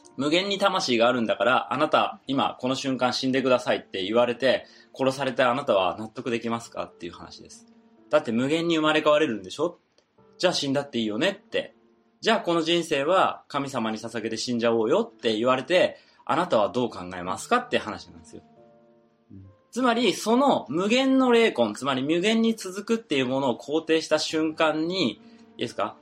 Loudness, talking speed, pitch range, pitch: -24 LUFS, 390 characters per minute, 115-180 Hz, 135 Hz